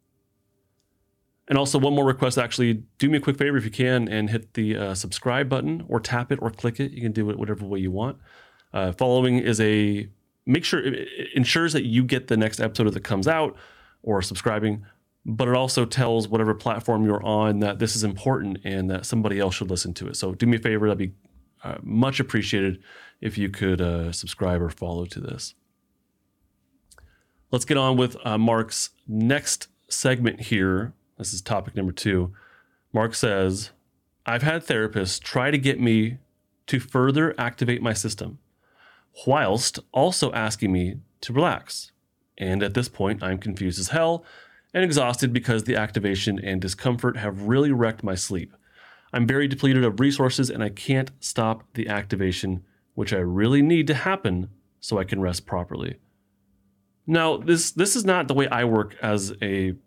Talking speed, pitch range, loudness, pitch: 180 wpm, 100-130 Hz, -24 LUFS, 110 Hz